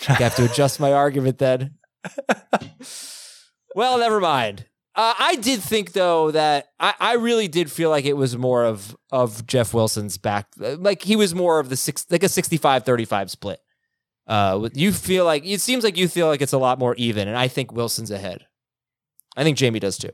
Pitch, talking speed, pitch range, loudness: 140 Hz, 195 wpm, 125-185 Hz, -20 LUFS